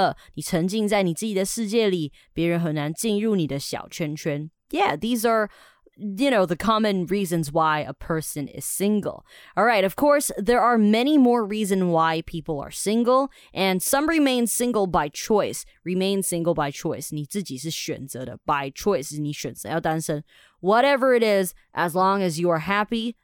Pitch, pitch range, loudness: 190 Hz, 160-220 Hz, -23 LUFS